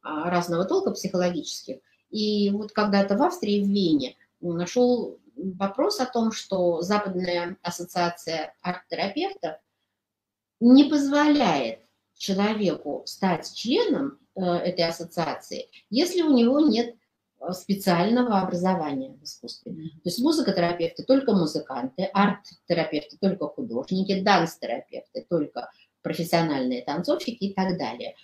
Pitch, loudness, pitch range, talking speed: 195 Hz, -25 LUFS, 175-245 Hz, 105 wpm